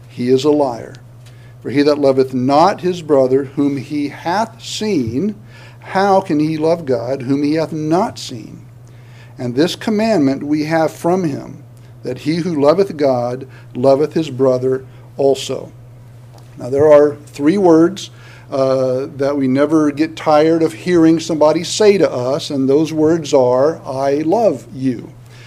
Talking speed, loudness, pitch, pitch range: 155 wpm, -15 LUFS, 140 Hz, 125-155 Hz